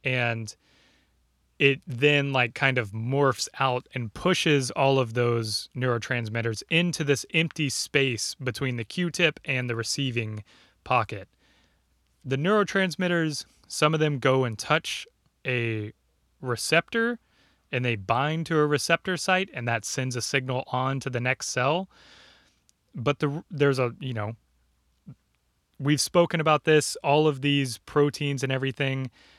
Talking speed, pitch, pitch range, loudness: 140 wpm, 135 Hz, 115-150 Hz, -26 LUFS